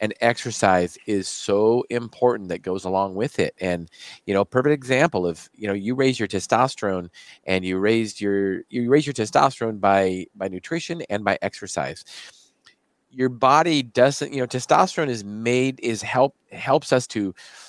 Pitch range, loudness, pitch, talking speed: 95-130 Hz, -22 LUFS, 110 Hz, 165 wpm